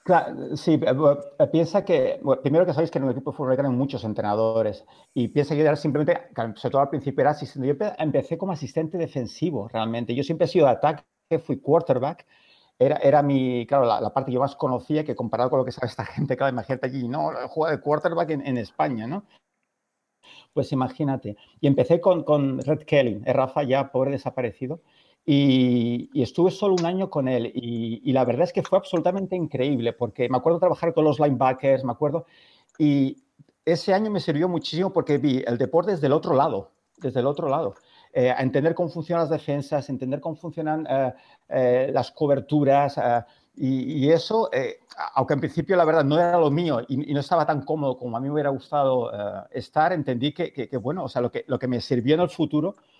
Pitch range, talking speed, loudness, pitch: 130-165 Hz, 210 wpm, -24 LUFS, 145 Hz